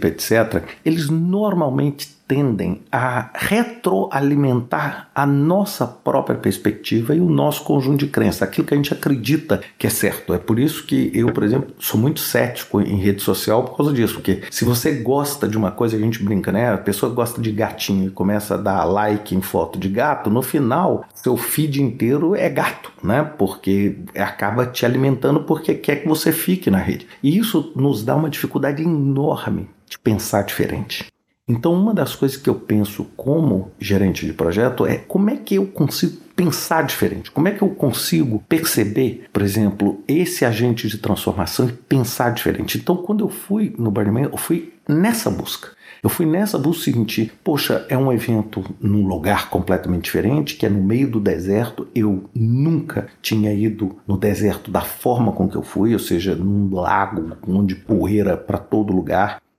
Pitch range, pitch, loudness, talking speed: 105-150 Hz, 120 Hz, -19 LUFS, 180 wpm